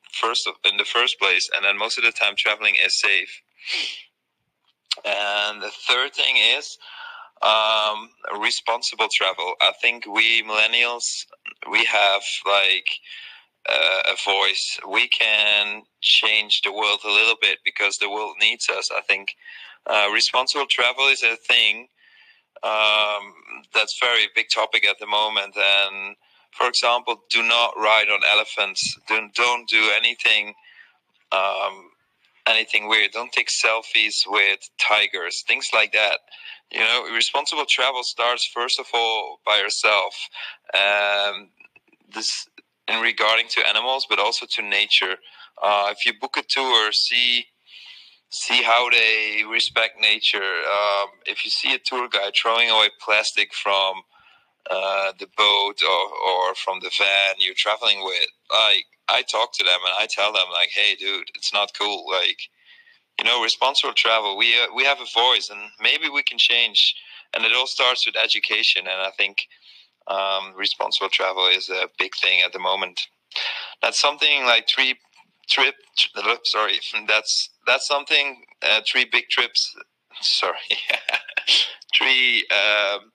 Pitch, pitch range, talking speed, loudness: 110 Hz, 100-120 Hz, 150 wpm, -19 LUFS